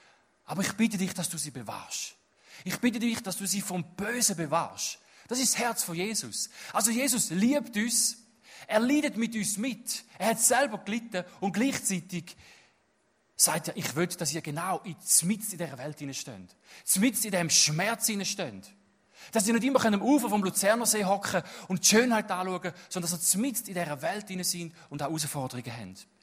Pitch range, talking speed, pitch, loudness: 170-230 Hz, 185 wpm, 195 Hz, -28 LUFS